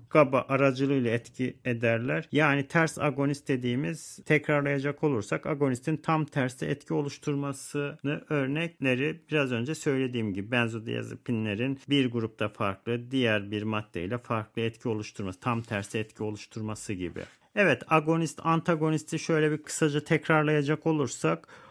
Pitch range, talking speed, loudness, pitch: 115-150 Hz, 120 wpm, -29 LUFS, 140 Hz